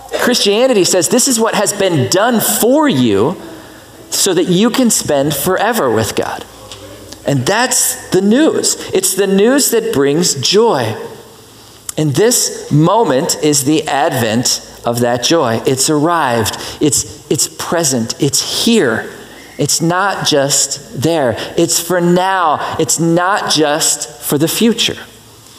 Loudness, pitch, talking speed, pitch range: -12 LUFS, 165 Hz, 135 wpm, 140-205 Hz